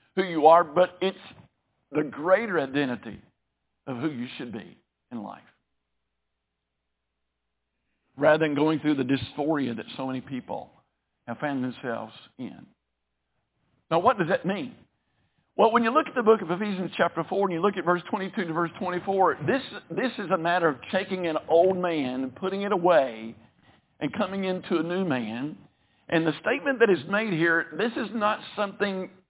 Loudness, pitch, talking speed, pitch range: -26 LUFS, 170 Hz, 180 wpm, 130-195 Hz